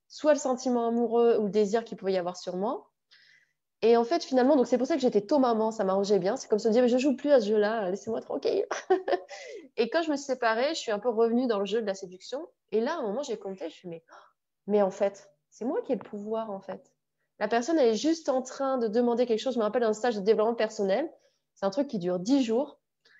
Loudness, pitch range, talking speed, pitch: -27 LUFS, 210-265 Hz, 275 wpm, 230 Hz